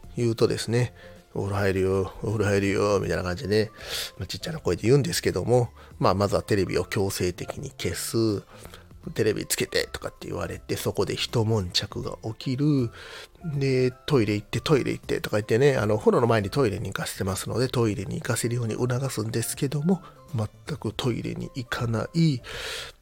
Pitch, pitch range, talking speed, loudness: 110 Hz, 100-125 Hz, 380 characters per minute, -26 LUFS